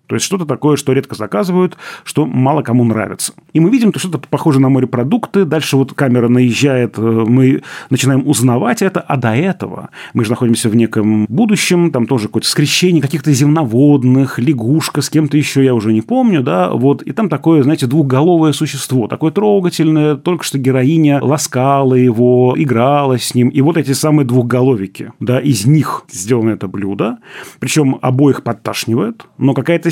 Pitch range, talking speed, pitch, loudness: 125-155 Hz, 170 wpm, 135 Hz, -13 LUFS